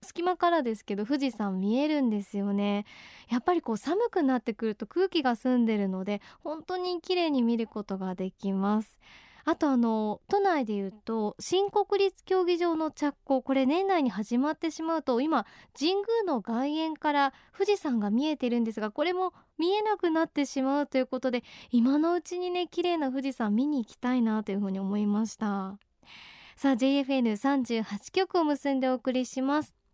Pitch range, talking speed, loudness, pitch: 225-330 Hz, 355 characters per minute, -29 LUFS, 270 Hz